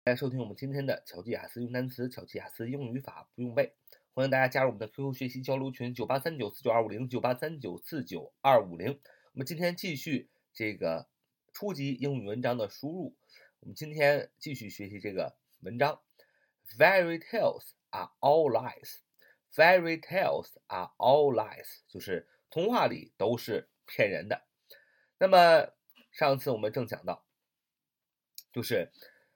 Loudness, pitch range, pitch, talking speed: -30 LUFS, 120-160 Hz, 135 Hz, 300 characters per minute